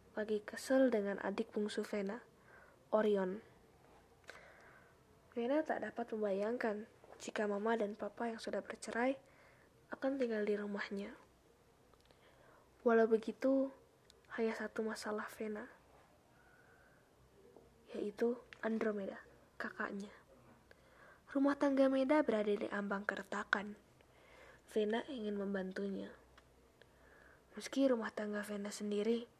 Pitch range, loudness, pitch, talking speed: 210-240 Hz, -39 LUFS, 220 Hz, 95 wpm